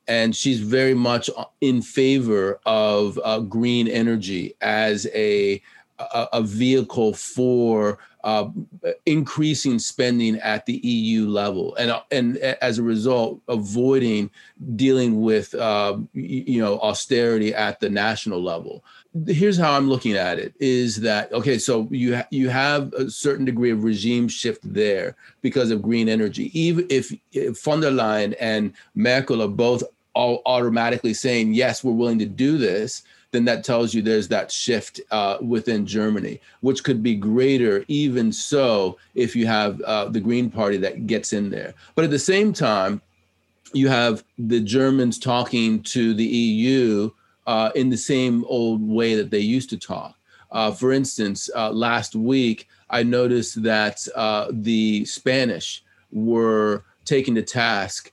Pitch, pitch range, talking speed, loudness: 115 Hz, 110-130 Hz, 155 wpm, -21 LUFS